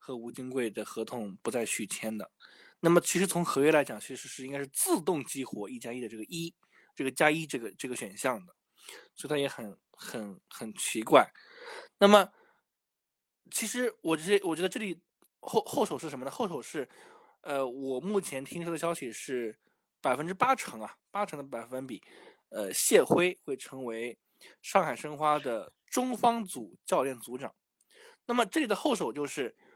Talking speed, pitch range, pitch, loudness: 260 characters per minute, 130-200 Hz, 155 Hz, -31 LUFS